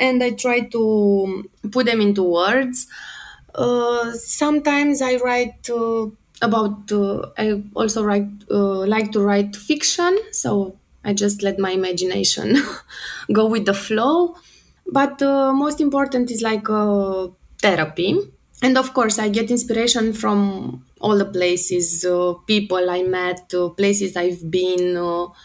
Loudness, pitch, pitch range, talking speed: -19 LUFS, 215 Hz, 190-245 Hz, 140 wpm